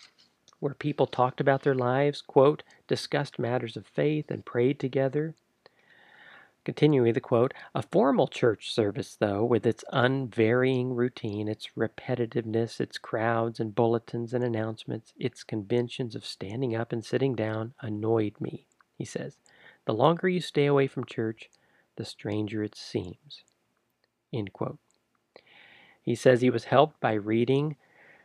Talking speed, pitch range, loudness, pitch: 140 wpm, 110-135 Hz, -28 LUFS, 120 Hz